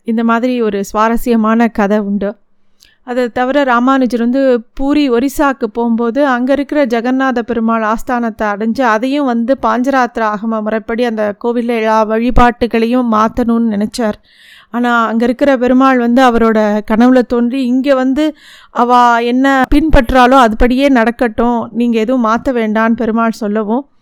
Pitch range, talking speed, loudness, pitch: 225-255 Hz, 125 wpm, -12 LUFS, 240 Hz